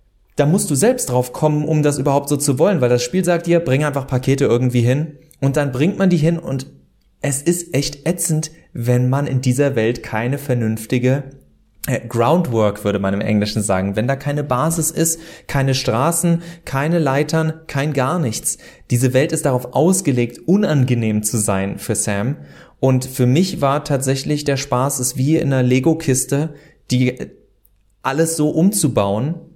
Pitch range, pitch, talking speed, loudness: 125-155 Hz, 135 Hz, 175 wpm, -18 LUFS